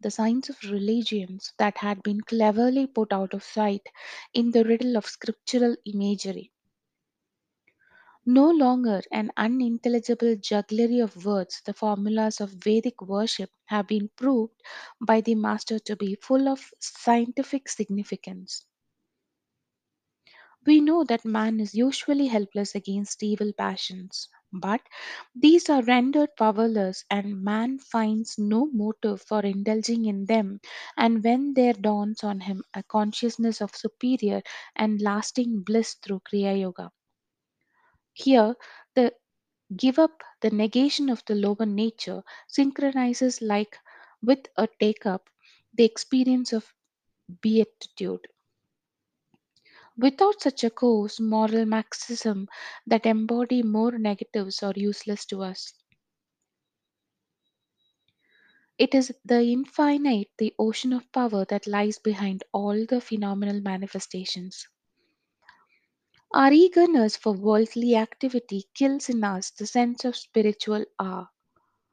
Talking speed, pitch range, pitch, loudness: 120 wpm, 205-245 Hz, 220 Hz, -25 LUFS